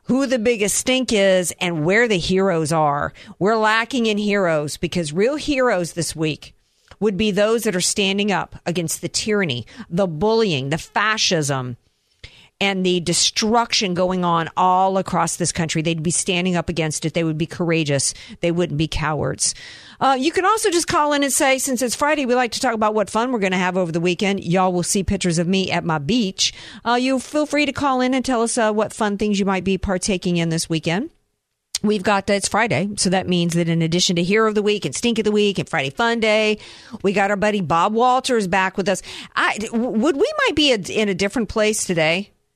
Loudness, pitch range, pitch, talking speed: -19 LUFS, 175-225 Hz, 195 Hz, 220 wpm